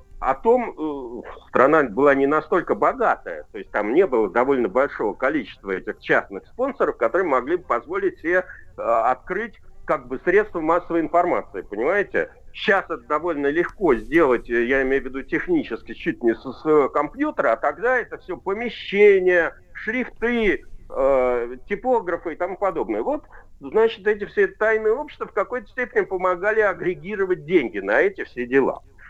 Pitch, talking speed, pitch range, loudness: 195 Hz, 150 wpm, 155-260 Hz, -21 LUFS